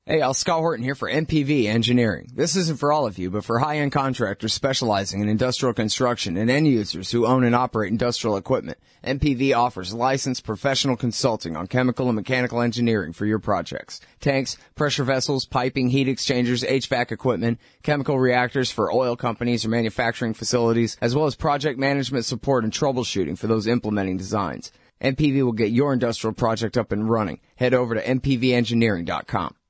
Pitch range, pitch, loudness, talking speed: 115-135 Hz, 125 Hz, -22 LUFS, 170 wpm